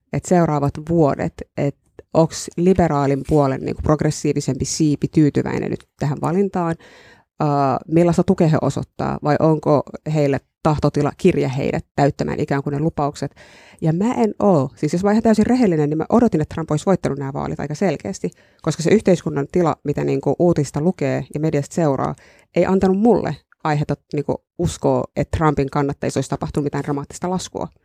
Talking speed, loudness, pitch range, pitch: 165 wpm, -19 LUFS, 140-175 Hz, 150 Hz